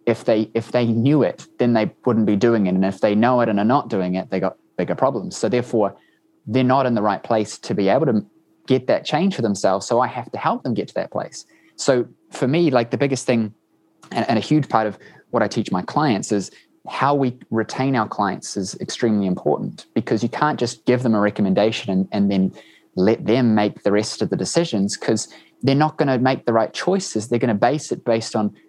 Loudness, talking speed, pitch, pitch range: -20 LUFS, 240 wpm, 115 Hz, 105-130 Hz